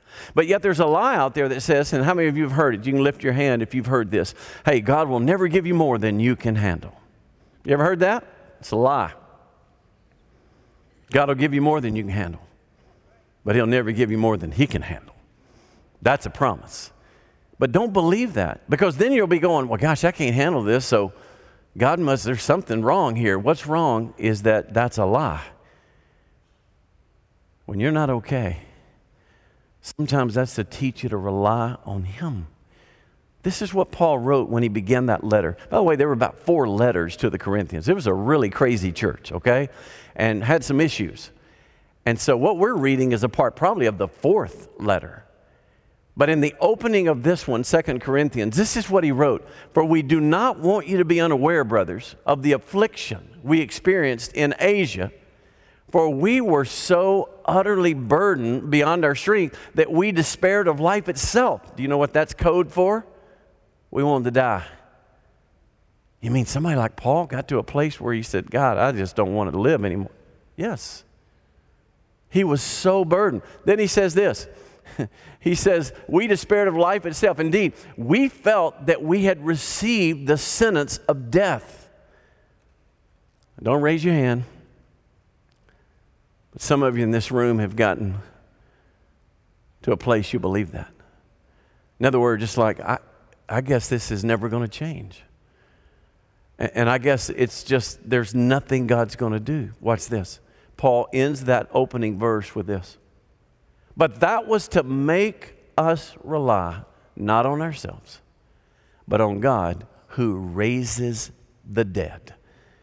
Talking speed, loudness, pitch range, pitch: 175 wpm, -21 LUFS, 110-160 Hz, 130 Hz